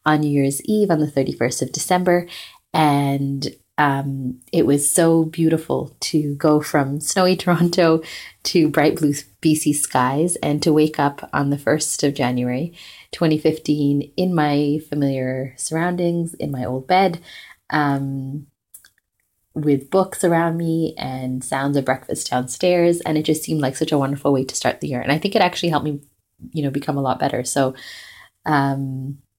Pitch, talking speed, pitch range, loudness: 145 Hz, 165 wpm, 135-165 Hz, -20 LUFS